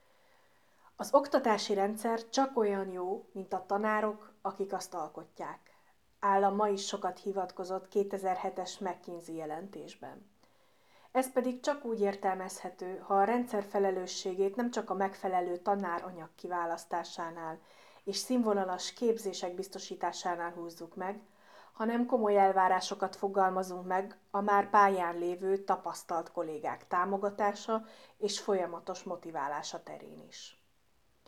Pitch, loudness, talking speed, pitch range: 195 Hz, -33 LUFS, 110 wpm, 180-205 Hz